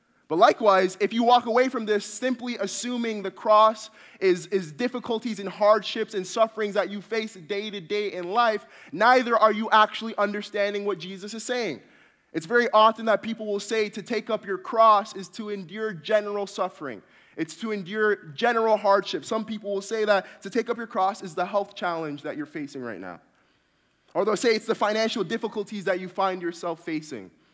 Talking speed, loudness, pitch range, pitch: 195 wpm, -25 LUFS, 195-225 Hz, 210 Hz